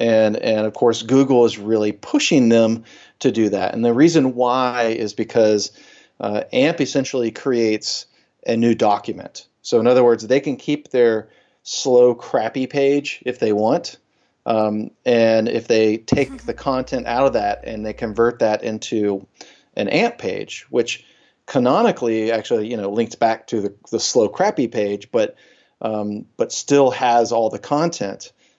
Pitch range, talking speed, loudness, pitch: 110-130 Hz, 165 wpm, -19 LUFS, 115 Hz